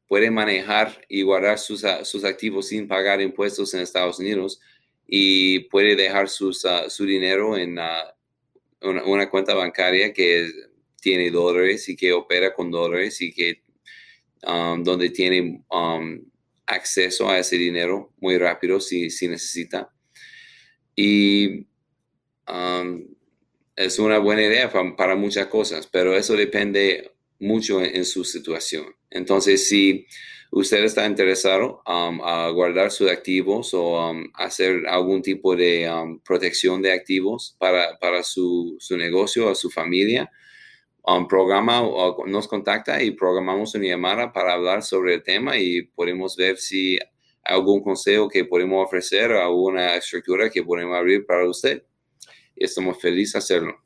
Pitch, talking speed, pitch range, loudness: 95 Hz, 150 wpm, 90-100 Hz, -21 LUFS